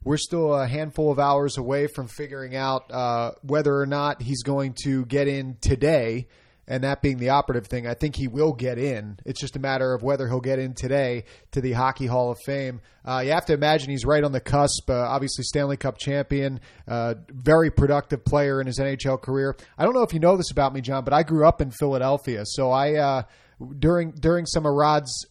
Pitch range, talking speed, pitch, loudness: 130-145 Hz, 225 wpm, 135 Hz, -24 LUFS